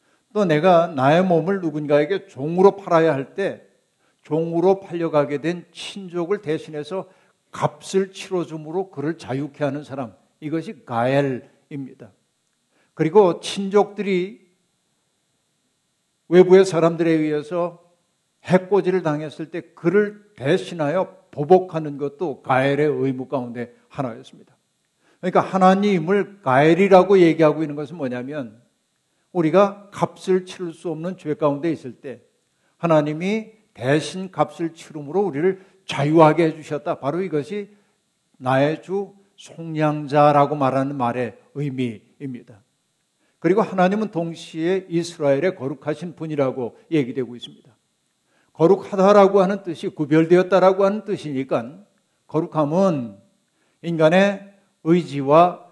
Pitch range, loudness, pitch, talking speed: 145-190 Hz, -20 LUFS, 165 Hz, 280 characters per minute